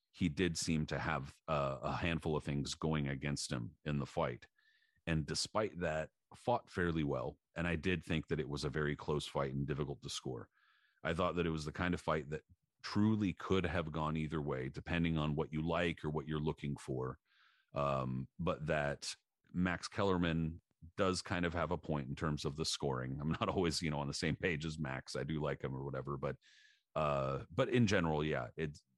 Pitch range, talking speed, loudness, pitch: 70-85 Hz, 215 wpm, -38 LUFS, 80 Hz